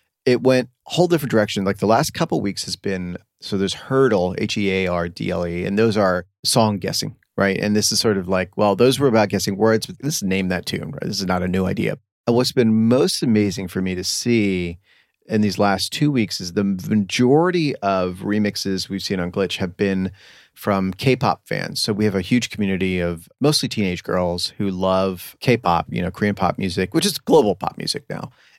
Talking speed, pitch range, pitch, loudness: 230 wpm, 95-115 Hz, 100 Hz, -20 LUFS